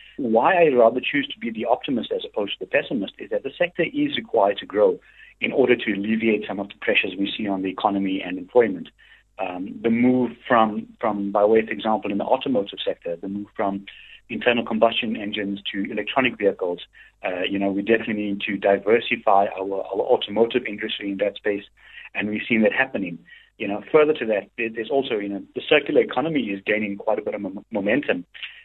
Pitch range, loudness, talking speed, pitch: 100-125 Hz, -22 LUFS, 205 wpm, 110 Hz